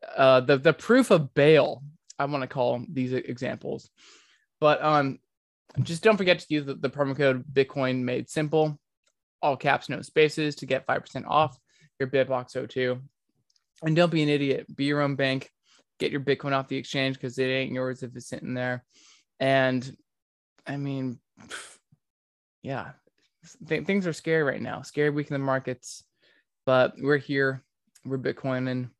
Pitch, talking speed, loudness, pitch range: 135 Hz, 170 wpm, -26 LUFS, 130-150 Hz